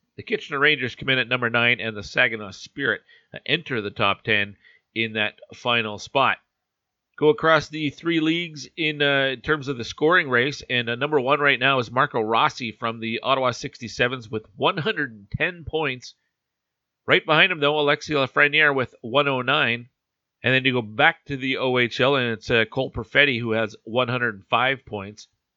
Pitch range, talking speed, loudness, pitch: 115-145 Hz, 175 wpm, -22 LUFS, 130 Hz